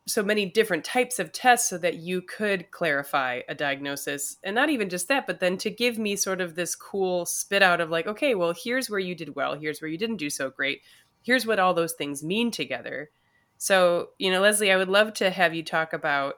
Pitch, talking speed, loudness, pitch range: 185 Hz, 235 wpm, -25 LUFS, 160-210 Hz